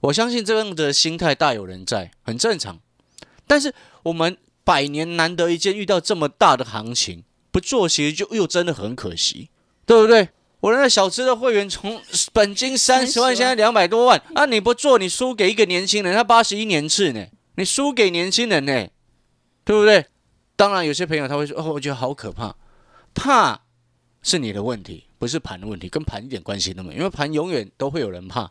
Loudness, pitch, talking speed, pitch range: -19 LUFS, 175 Hz, 300 characters per minute, 130-220 Hz